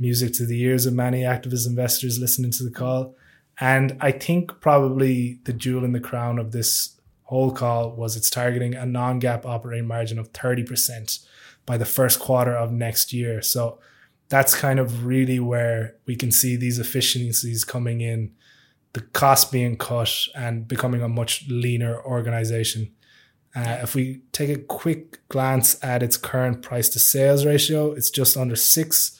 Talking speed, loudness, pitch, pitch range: 170 wpm, -21 LUFS, 125 Hz, 120-130 Hz